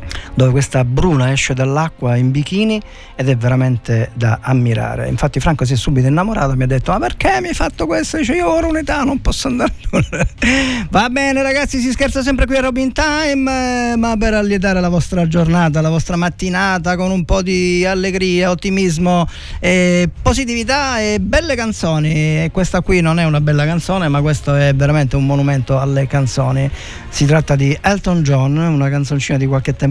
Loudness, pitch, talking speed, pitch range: -15 LUFS, 170 Hz, 185 wpm, 140-205 Hz